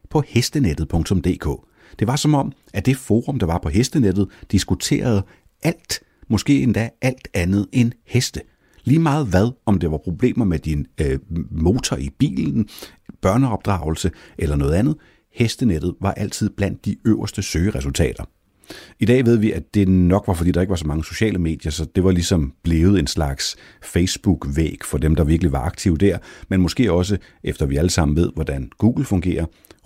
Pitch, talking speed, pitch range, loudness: 95 Hz, 175 wpm, 80-110 Hz, -20 LUFS